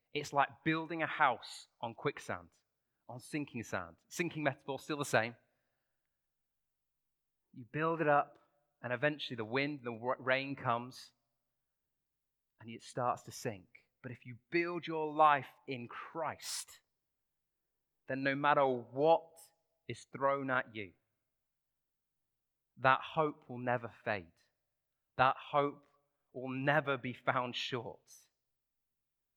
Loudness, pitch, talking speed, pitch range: -36 LUFS, 135 Hz, 120 wpm, 125-150 Hz